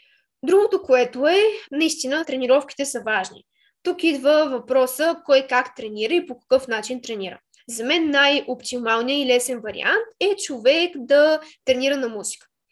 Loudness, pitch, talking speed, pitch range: -20 LUFS, 270 Hz, 140 wpm, 245-310 Hz